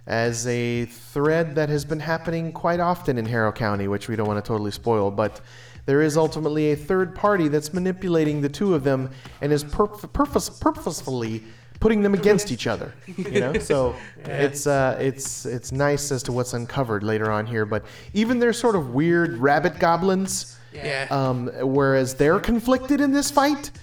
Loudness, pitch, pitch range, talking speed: -23 LUFS, 145 Hz, 120-180 Hz, 180 wpm